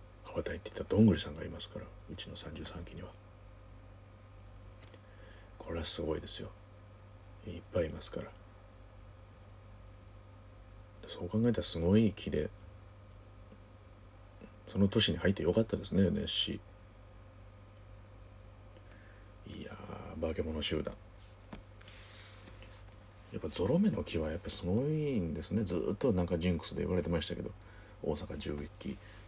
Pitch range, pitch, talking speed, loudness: 95-105 Hz, 105 Hz, 255 characters per minute, -34 LUFS